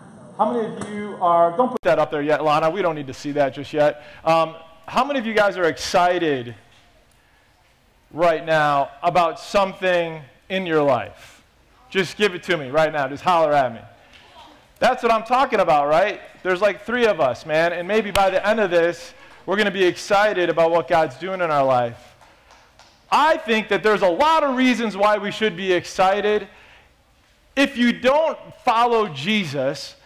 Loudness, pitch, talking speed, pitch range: -20 LUFS, 180 Hz, 190 wpm, 155-215 Hz